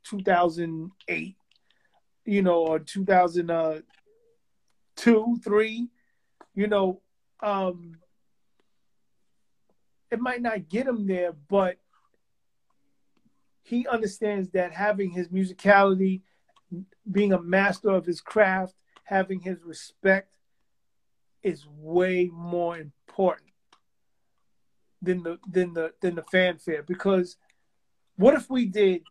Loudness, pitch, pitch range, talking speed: -25 LUFS, 190 Hz, 175-210 Hz, 105 wpm